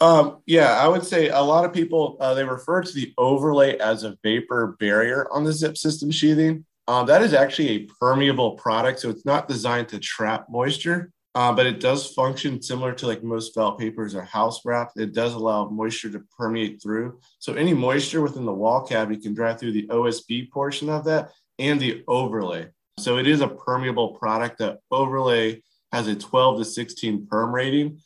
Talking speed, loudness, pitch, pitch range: 195 wpm, -22 LUFS, 125 Hz, 115-145 Hz